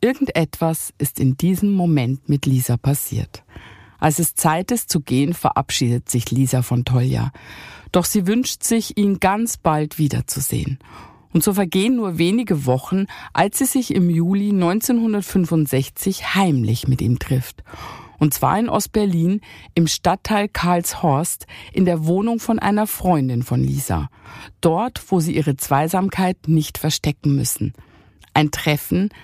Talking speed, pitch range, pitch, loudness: 140 wpm, 130-190 Hz, 155 Hz, -19 LUFS